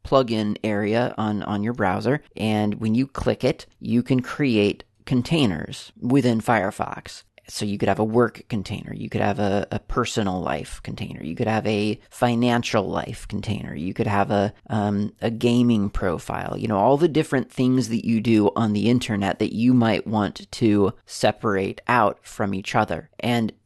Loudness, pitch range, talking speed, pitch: -23 LUFS, 105-120 Hz, 180 wpm, 110 Hz